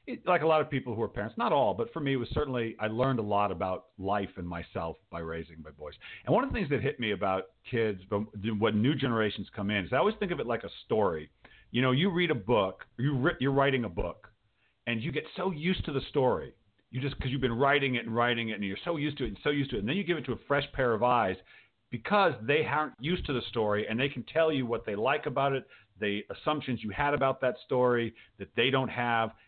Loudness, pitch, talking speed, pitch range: -30 LUFS, 125 Hz, 265 wpm, 105-140 Hz